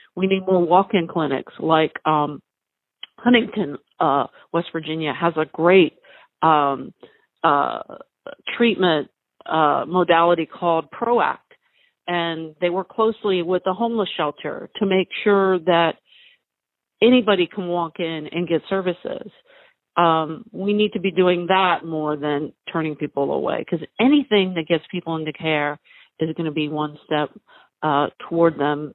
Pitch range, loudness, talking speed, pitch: 160-205 Hz, -21 LUFS, 140 wpm, 175 Hz